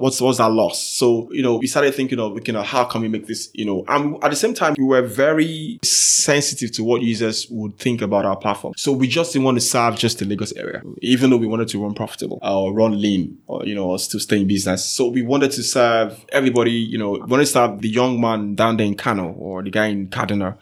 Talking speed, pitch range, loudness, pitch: 260 wpm, 105-130 Hz, -19 LUFS, 115 Hz